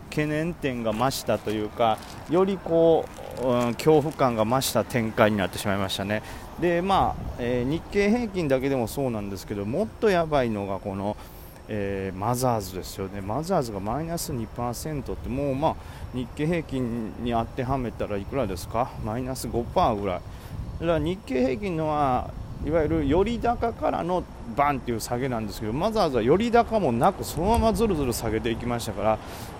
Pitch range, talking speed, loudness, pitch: 105-155 Hz, 370 characters per minute, -26 LUFS, 120 Hz